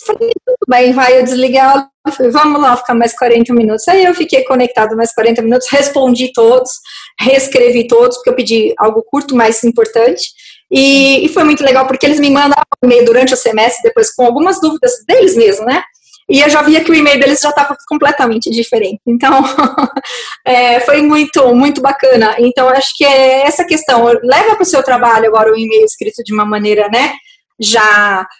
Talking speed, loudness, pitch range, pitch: 190 wpm, -9 LUFS, 235-295 Hz, 265 Hz